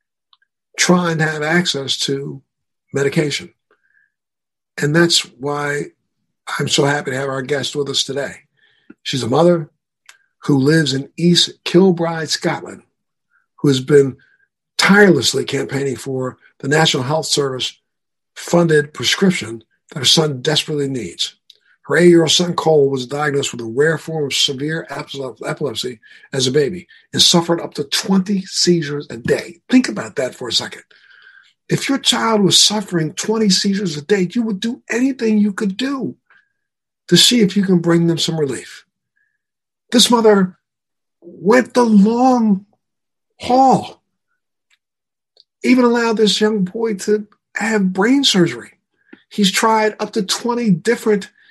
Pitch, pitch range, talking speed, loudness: 175 Hz, 145-215 Hz, 145 wpm, -16 LUFS